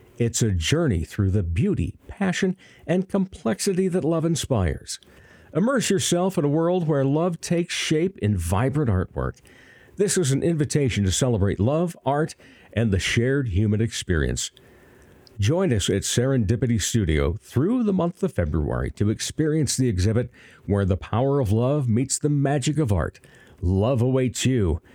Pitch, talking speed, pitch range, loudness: 125 Hz, 155 wpm, 100-160 Hz, -23 LUFS